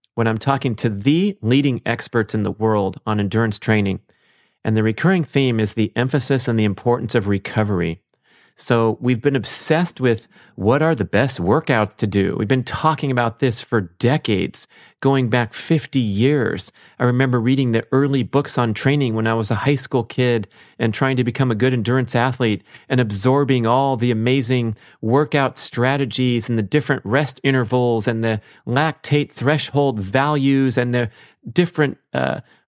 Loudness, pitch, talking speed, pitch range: -19 LUFS, 125 Hz, 170 wpm, 115-135 Hz